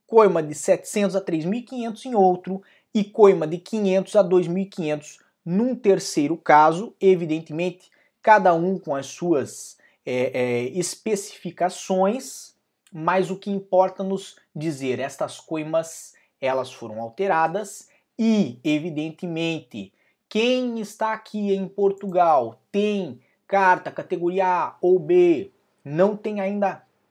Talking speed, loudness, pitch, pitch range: 115 wpm, -22 LUFS, 190 Hz, 165-205 Hz